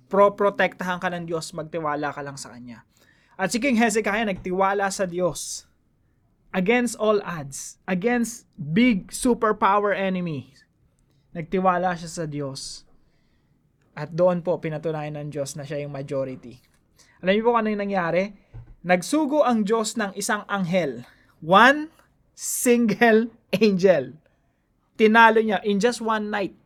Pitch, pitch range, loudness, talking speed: 185 Hz, 150-215 Hz, -22 LUFS, 130 wpm